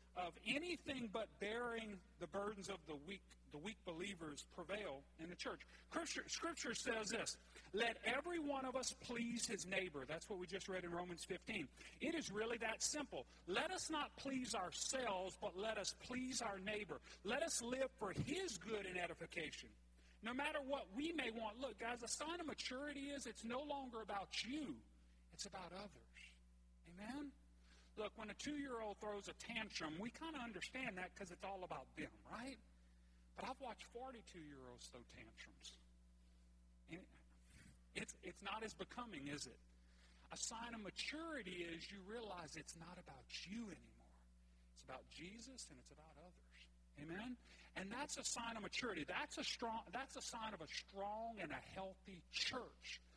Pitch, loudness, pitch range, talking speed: 205 Hz, -48 LUFS, 160-245 Hz, 175 wpm